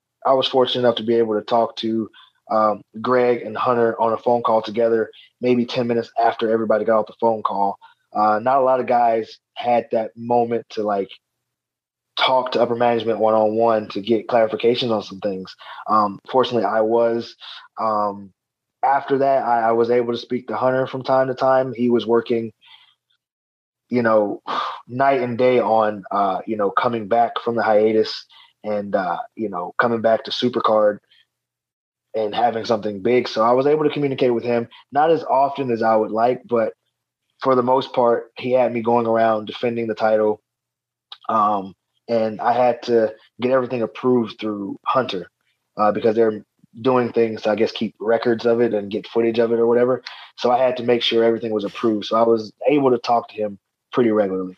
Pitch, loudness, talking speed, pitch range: 115 Hz, -20 LUFS, 195 wpm, 110-125 Hz